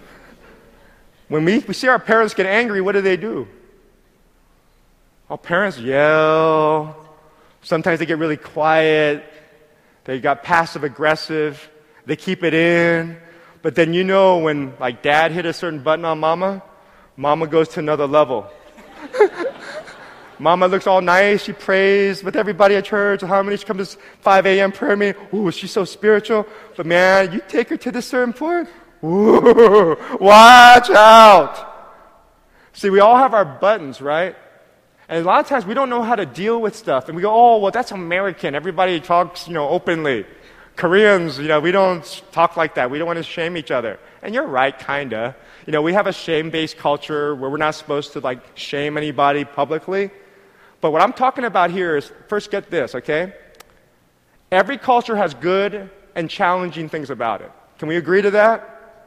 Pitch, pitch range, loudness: 175 Hz, 155-205 Hz, -16 LUFS